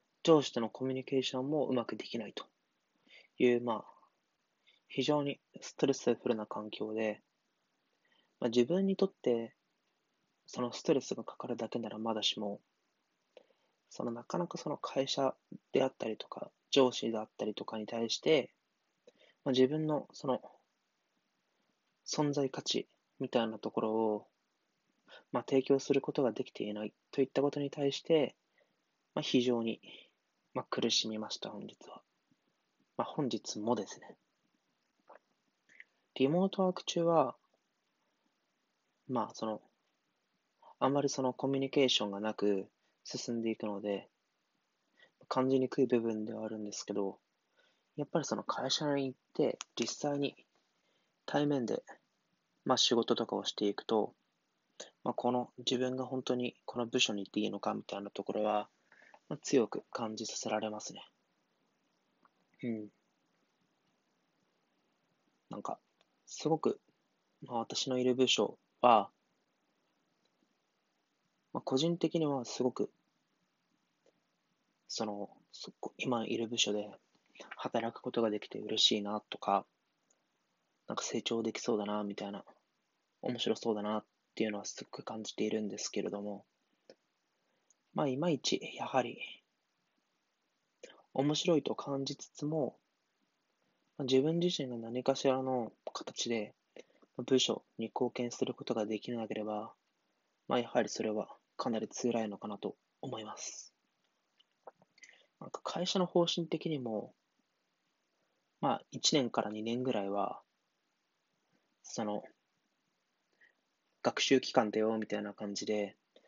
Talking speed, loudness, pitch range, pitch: 245 characters per minute, -35 LUFS, 110-135 Hz, 120 Hz